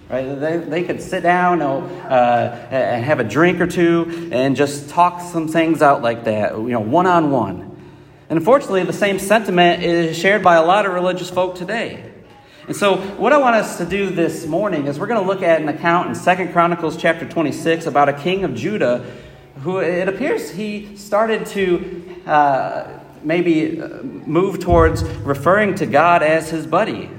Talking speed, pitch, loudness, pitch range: 190 wpm, 170 Hz, -17 LUFS, 145-180 Hz